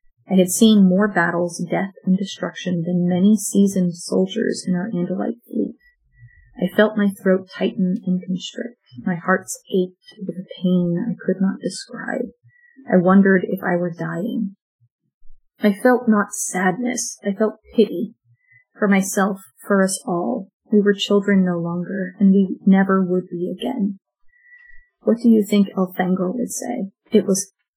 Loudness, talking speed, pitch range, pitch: -20 LUFS, 155 wpm, 180-215 Hz, 195 Hz